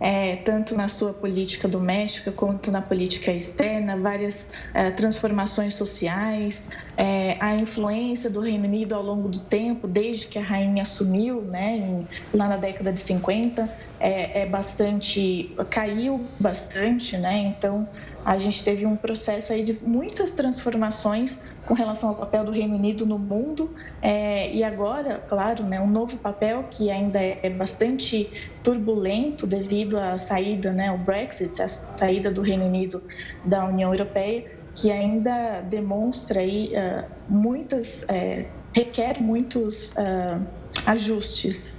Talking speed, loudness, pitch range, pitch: 140 wpm, -25 LUFS, 195-220 Hz, 205 Hz